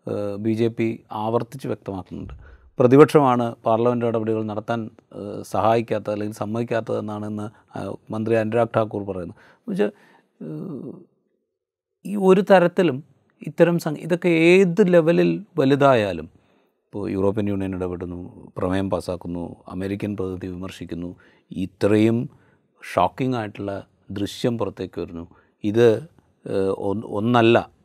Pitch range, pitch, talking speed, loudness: 95-130 Hz, 110 Hz, 90 wpm, -21 LUFS